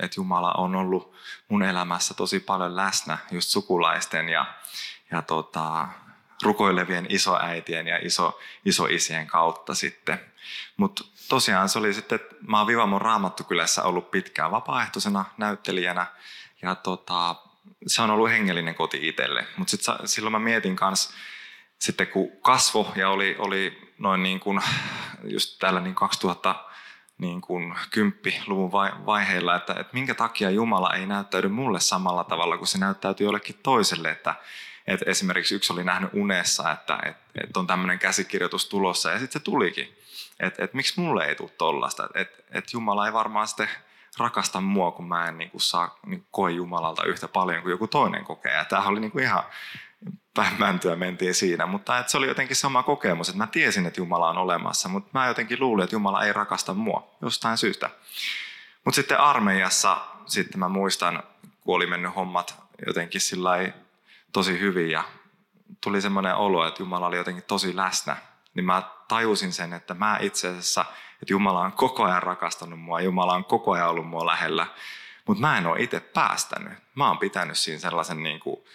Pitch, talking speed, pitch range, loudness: 95 Hz, 165 wpm, 90-105 Hz, -25 LUFS